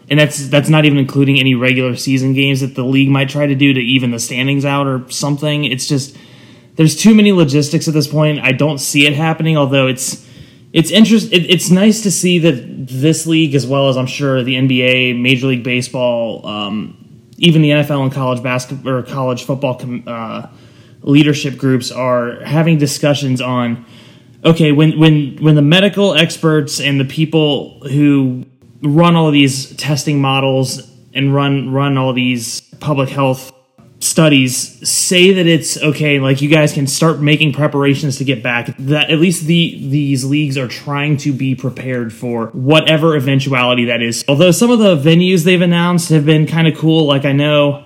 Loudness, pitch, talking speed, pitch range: -13 LUFS, 140 Hz, 185 wpm, 130-155 Hz